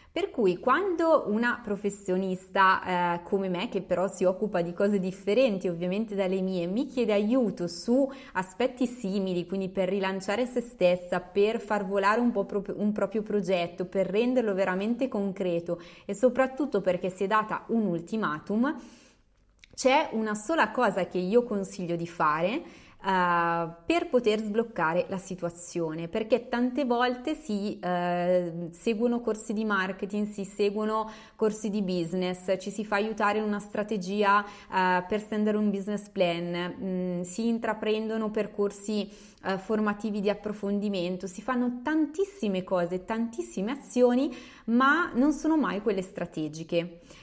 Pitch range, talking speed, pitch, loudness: 185-230 Hz, 140 wpm, 205 Hz, -28 LUFS